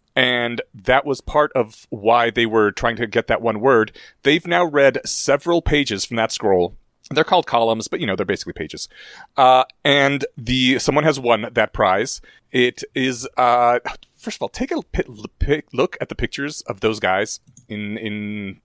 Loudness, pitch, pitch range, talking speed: -19 LUFS, 125 Hz, 110-140 Hz, 185 wpm